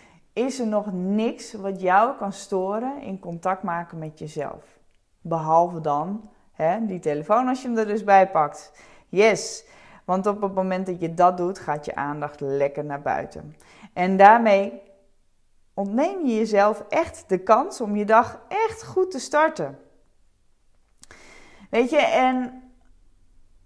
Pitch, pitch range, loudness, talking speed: 195 Hz, 165-220 Hz, -22 LUFS, 145 wpm